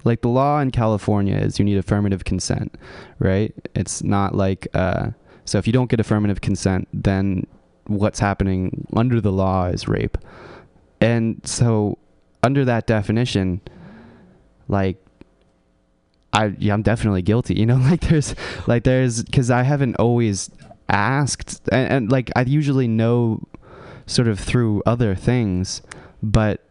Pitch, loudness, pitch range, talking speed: 110 Hz, -20 LUFS, 100-125 Hz, 145 wpm